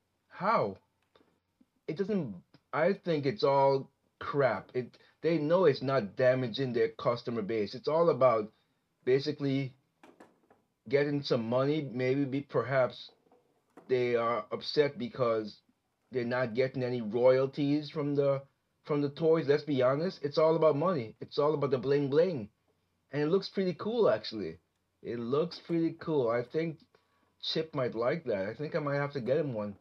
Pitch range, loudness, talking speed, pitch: 125-155 Hz, -31 LUFS, 155 wpm, 140 Hz